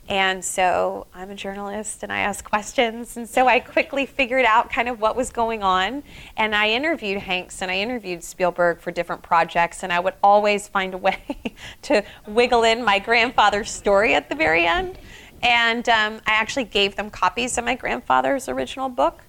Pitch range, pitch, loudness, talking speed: 185-240 Hz, 205 Hz, -20 LUFS, 190 wpm